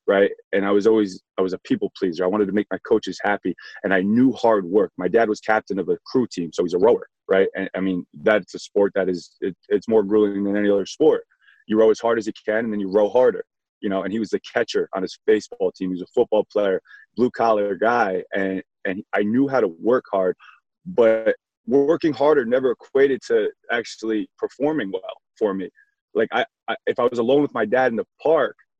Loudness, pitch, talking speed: -21 LUFS, 115 Hz, 240 wpm